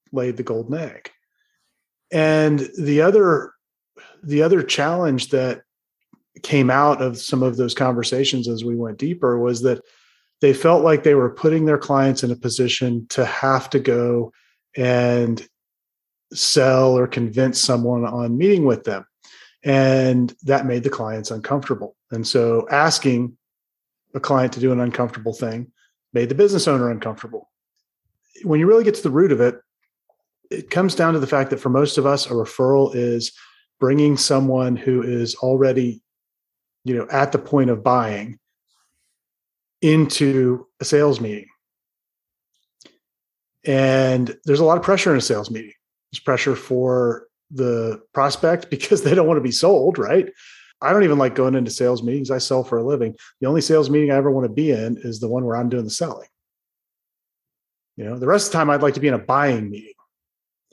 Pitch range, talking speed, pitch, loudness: 120-145 Hz, 175 wpm, 130 Hz, -19 LUFS